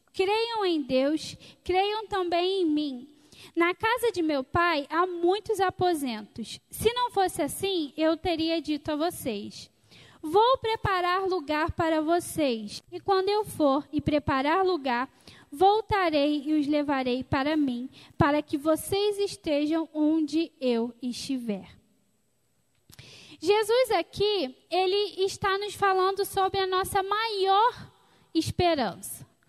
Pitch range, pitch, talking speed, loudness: 300-390 Hz, 345 Hz, 120 wpm, -27 LUFS